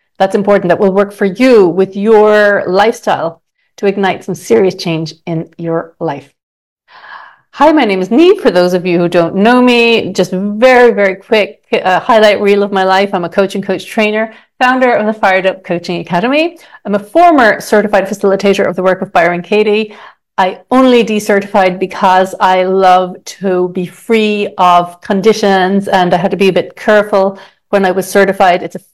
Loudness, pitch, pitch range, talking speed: -10 LUFS, 195 Hz, 185-215 Hz, 185 wpm